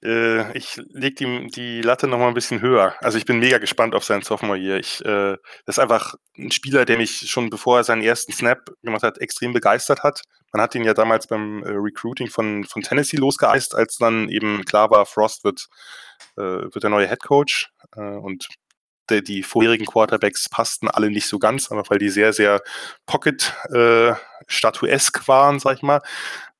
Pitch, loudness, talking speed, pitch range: 115 Hz, -19 LUFS, 190 wpm, 105-125 Hz